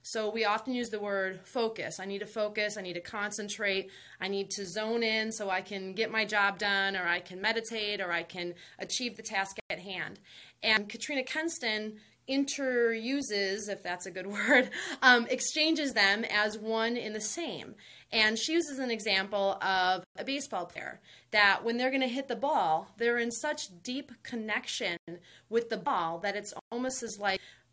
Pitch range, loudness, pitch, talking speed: 195-240 Hz, -30 LUFS, 215 Hz, 185 wpm